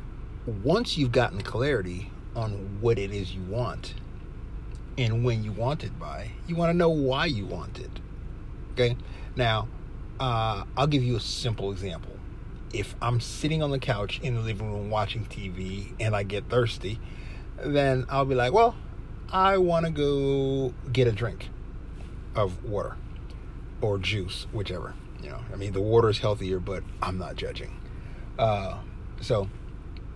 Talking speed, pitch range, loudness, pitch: 160 wpm, 100-130 Hz, -28 LUFS, 110 Hz